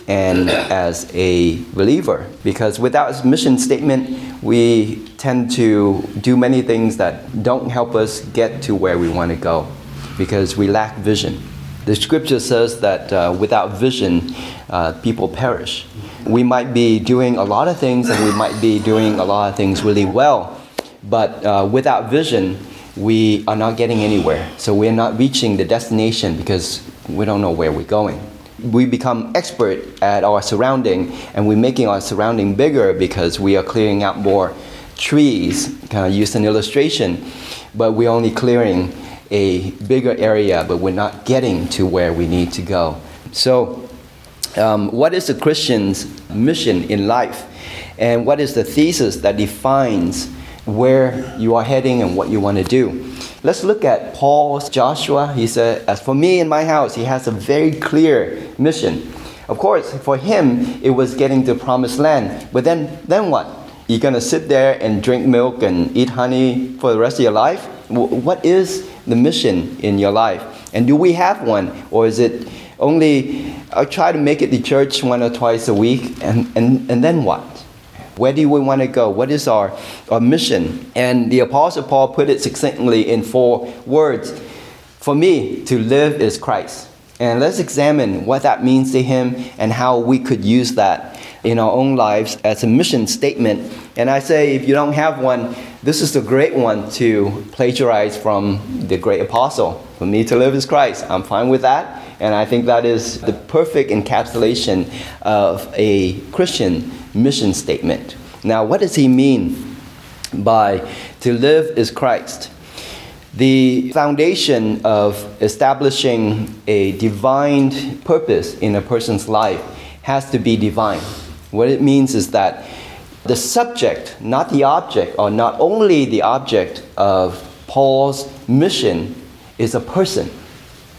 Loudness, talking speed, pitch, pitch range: -16 LUFS, 170 wpm, 120 Hz, 105-135 Hz